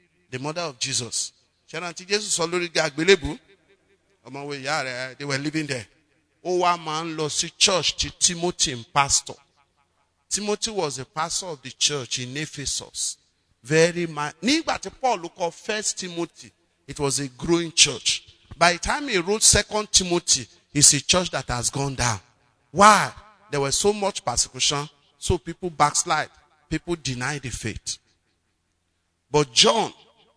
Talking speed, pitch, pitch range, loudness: 125 wpm, 150 Hz, 125-175 Hz, -22 LUFS